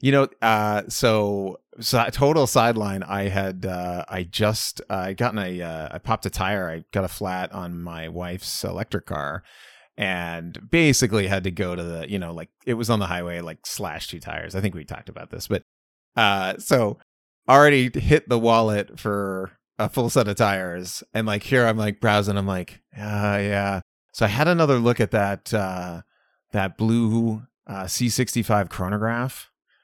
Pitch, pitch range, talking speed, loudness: 105 Hz, 90-115 Hz, 185 wpm, -23 LUFS